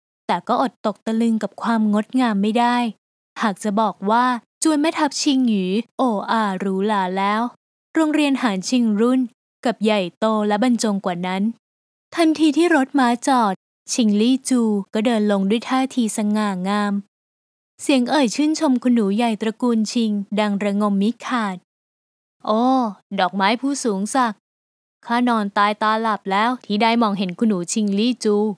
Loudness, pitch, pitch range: -20 LUFS, 225 Hz, 205-250 Hz